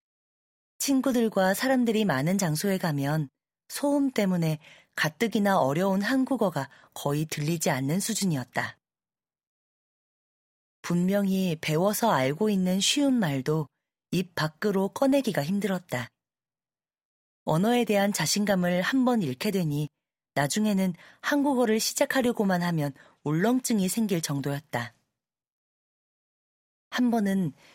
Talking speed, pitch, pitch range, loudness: 245 characters per minute, 190 Hz, 155-220 Hz, -26 LUFS